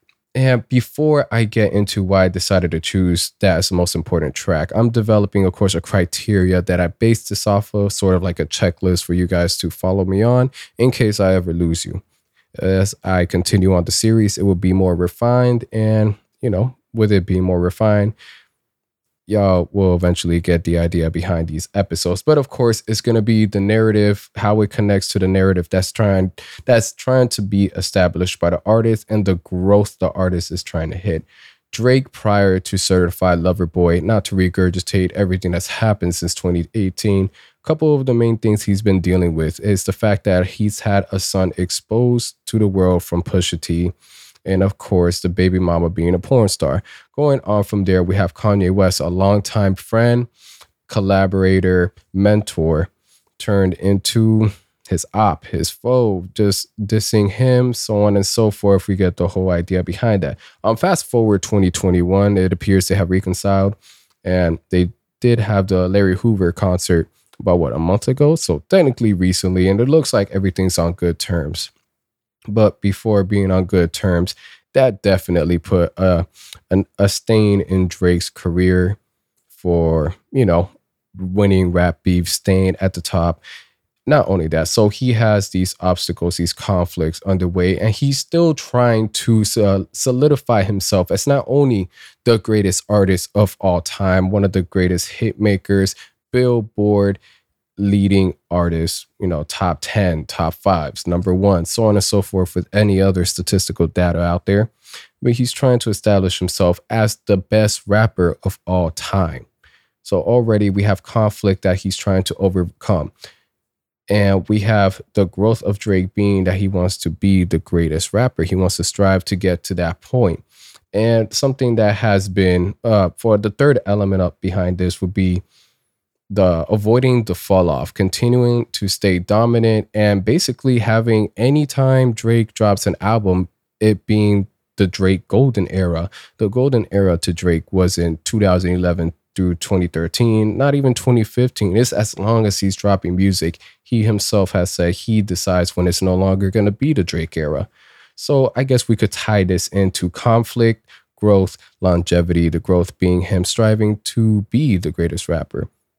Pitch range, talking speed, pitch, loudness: 90-110 Hz, 175 wpm, 95 Hz, -17 LUFS